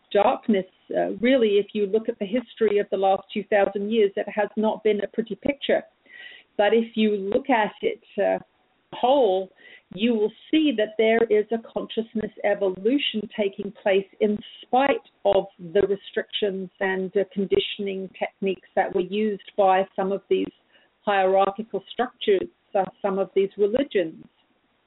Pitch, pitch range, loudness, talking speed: 210 Hz, 195-225 Hz, -24 LUFS, 150 wpm